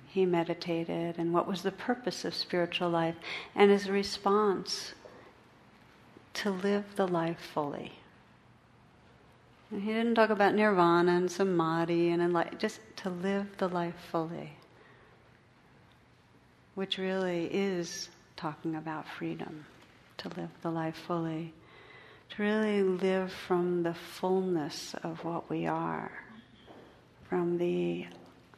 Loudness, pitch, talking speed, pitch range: -31 LUFS, 175 Hz, 120 wpm, 170-195 Hz